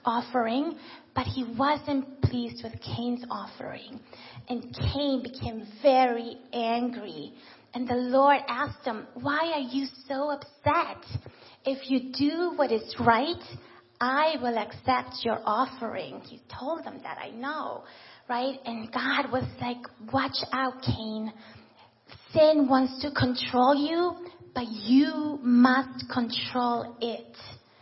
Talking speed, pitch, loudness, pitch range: 125 wpm, 255 Hz, -28 LUFS, 235-280 Hz